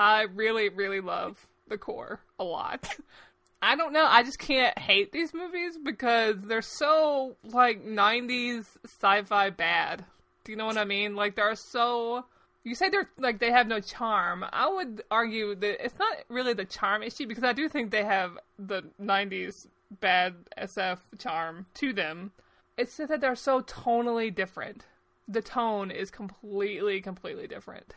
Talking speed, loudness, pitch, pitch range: 165 wpm, -28 LUFS, 220 Hz, 200-250 Hz